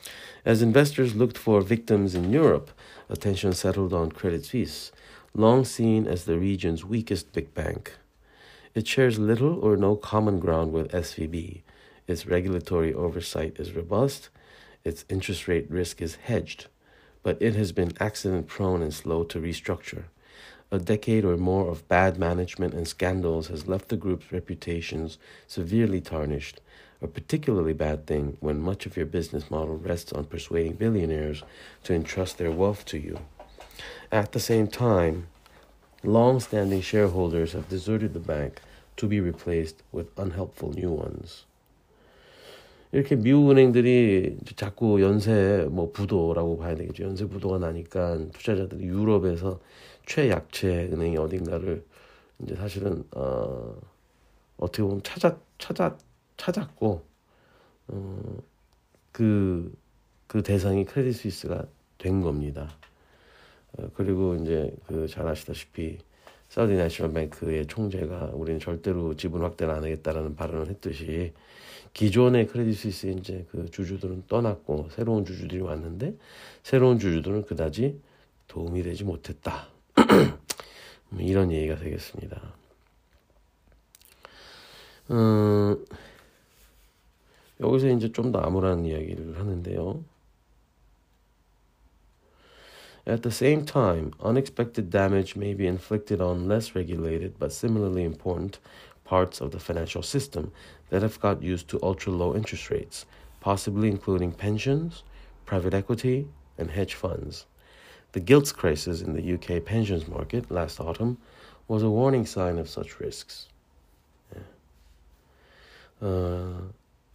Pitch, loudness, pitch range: 95 Hz, -27 LUFS, 80-105 Hz